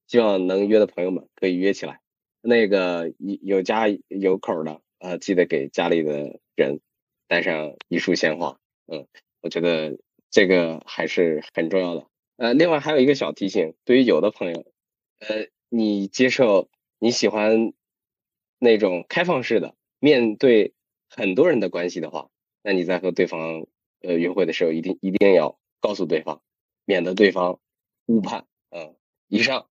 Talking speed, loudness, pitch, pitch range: 235 characters per minute, -21 LUFS, 95 Hz, 85-105 Hz